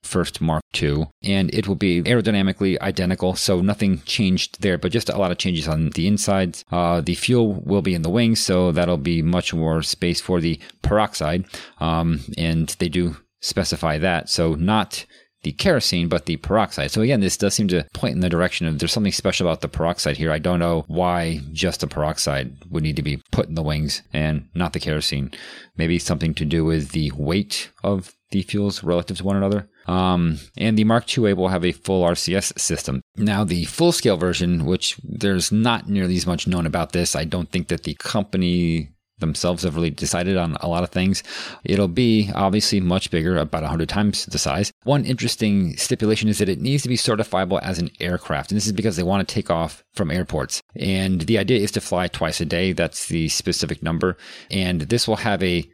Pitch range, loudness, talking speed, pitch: 80-100 Hz, -21 LUFS, 210 wpm, 90 Hz